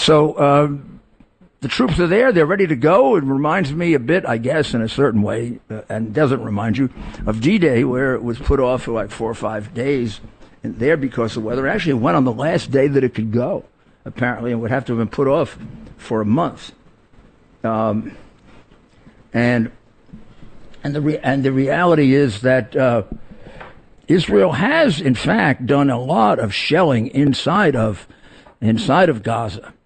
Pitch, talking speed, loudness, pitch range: 125 Hz, 185 wpm, -17 LUFS, 115-140 Hz